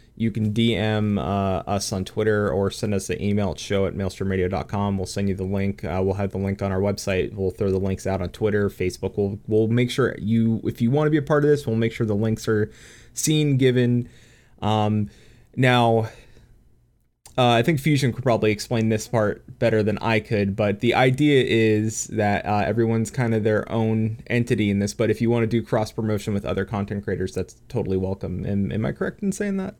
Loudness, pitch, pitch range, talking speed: -23 LUFS, 110 Hz, 100-115 Hz, 220 wpm